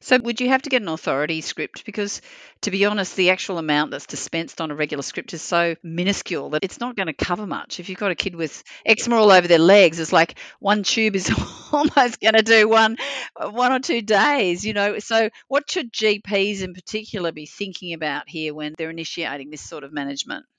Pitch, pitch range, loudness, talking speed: 195 Hz, 165-220 Hz, -20 LUFS, 220 wpm